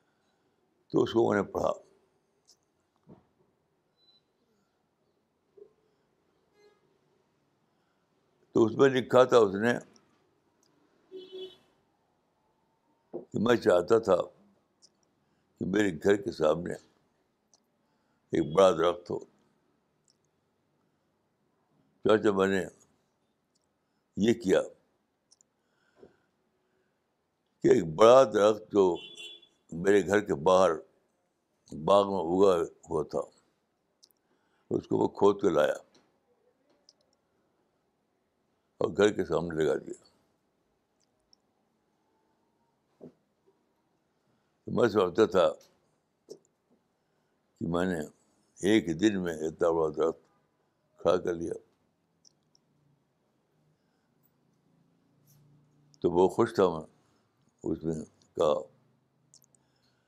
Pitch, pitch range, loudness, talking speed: 110 Hz, 95-145 Hz, -27 LUFS, 80 wpm